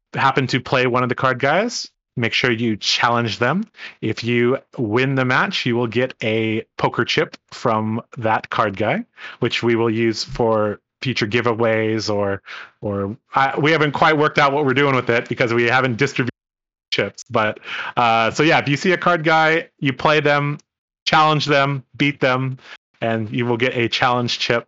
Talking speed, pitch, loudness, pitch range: 185 wpm, 125 Hz, -19 LUFS, 115-145 Hz